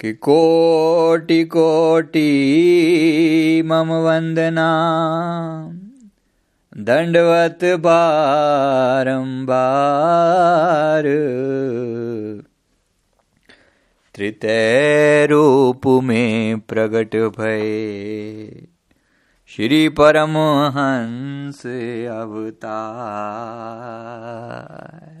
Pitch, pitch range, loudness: 145 Hz, 115-160 Hz, -16 LUFS